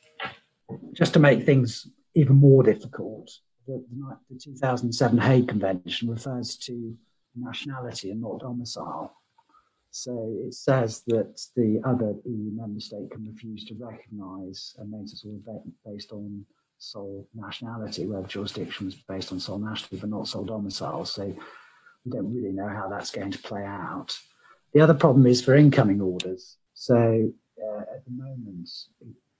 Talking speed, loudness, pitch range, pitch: 160 wpm, -24 LUFS, 100-125 Hz, 115 Hz